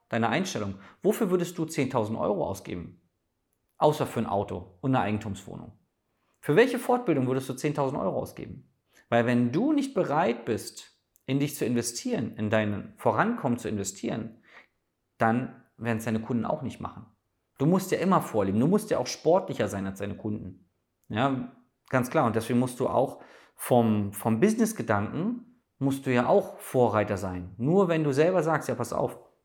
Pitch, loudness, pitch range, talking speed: 120 Hz, -27 LUFS, 105-150 Hz, 175 wpm